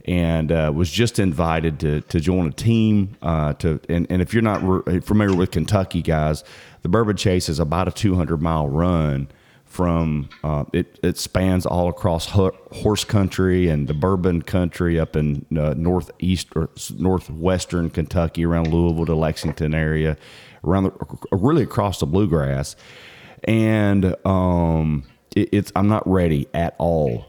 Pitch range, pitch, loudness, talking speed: 80-95 Hz, 85 Hz, -21 LUFS, 160 wpm